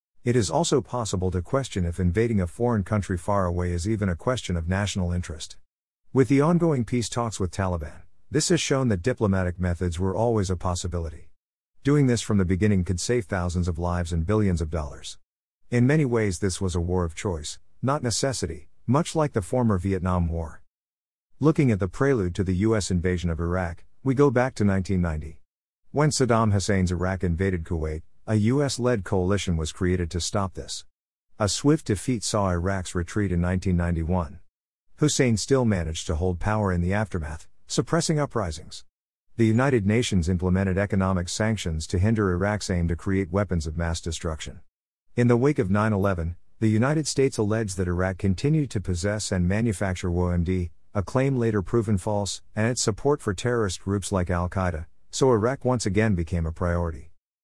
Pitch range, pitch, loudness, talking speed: 90-115 Hz, 95 Hz, -25 LUFS, 180 wpm